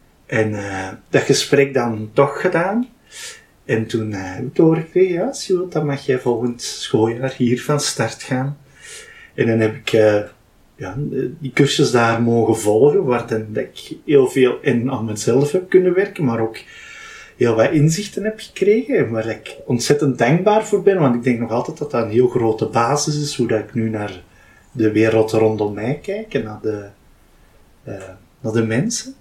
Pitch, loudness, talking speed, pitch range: 125 Hz, -18 LUFS, 175 wpm, 110-155 Hz